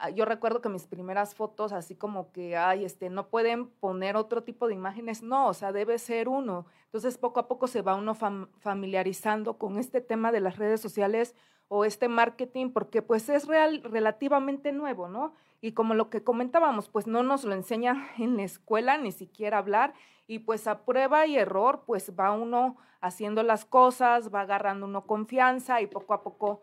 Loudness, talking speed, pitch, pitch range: -29 LUFS, 190 wpm, 220 Hz, 200-245 Hz